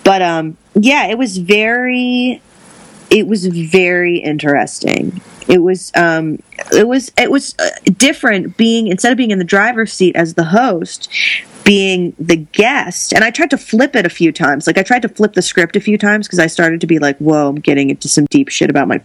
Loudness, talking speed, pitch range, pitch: -12 LUFS, 210 wpm, 170-235 Hz, 195 Hz